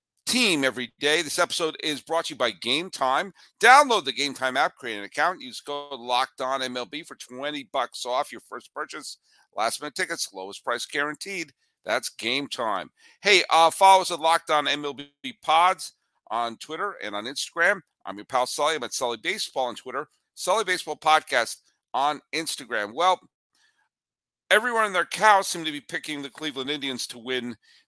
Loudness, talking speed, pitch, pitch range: -24 LUFS, 180 wpm, 150 Hz, 135-180 Hz